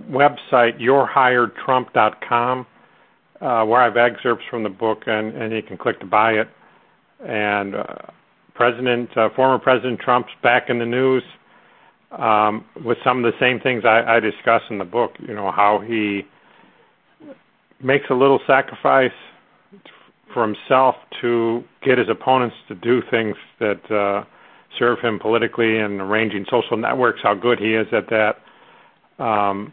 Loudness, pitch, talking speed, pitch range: -19 LUFS, 115 Hz, 145 wpm, 105-125 Hz